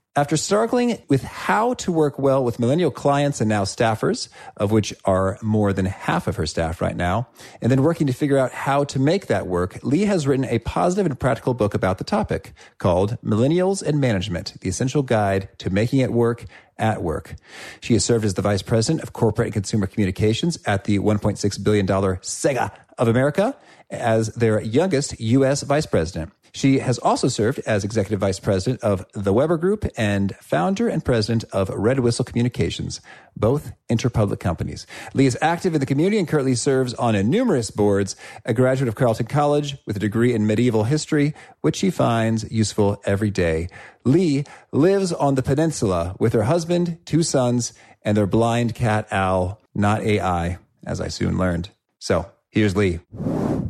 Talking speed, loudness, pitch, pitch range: 180 wpm, -21 LUFS, 115 Hz, 105-140 Hz